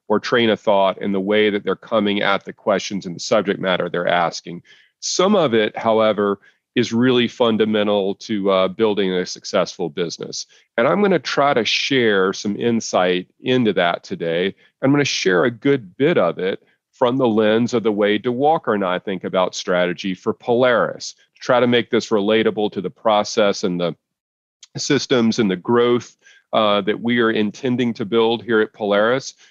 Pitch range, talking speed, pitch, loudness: 100-120 Hz, 180 wpm, 110 Hz, -19 LUFS